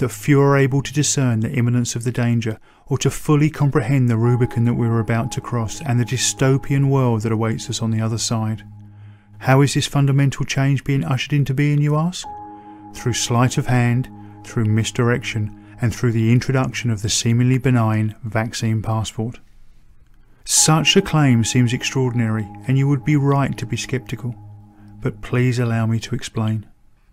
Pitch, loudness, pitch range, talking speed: 120 Hz, -19 LUFS, 110-135 Hz, 175 wpm